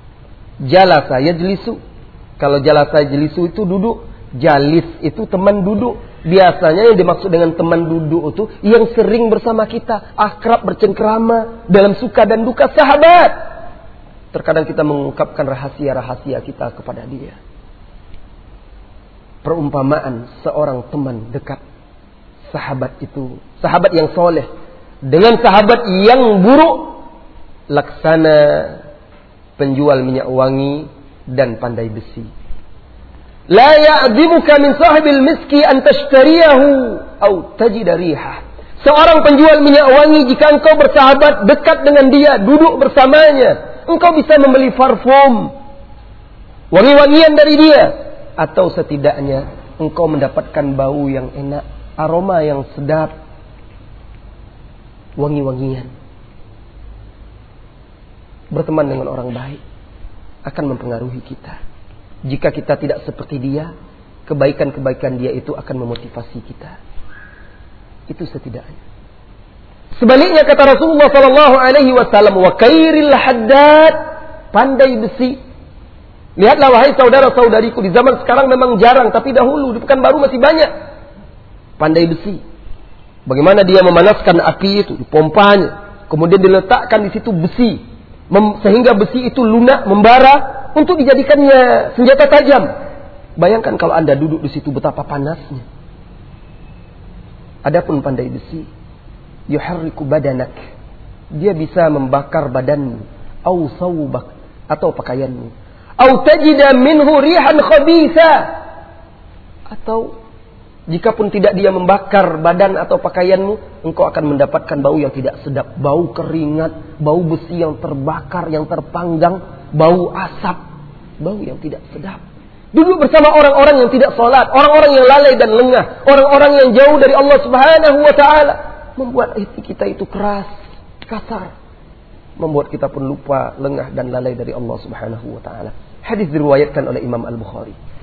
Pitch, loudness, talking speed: 175 Hz, -10 LUFS, 110 wpm